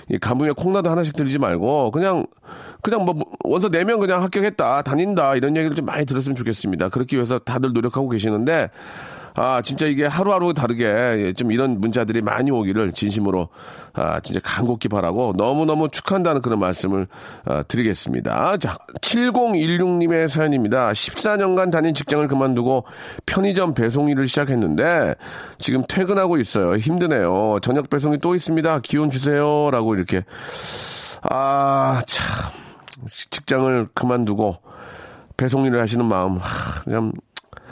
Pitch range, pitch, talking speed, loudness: 115-160 Hz, 135 Hz, 335 characters per minute, -20 LUFS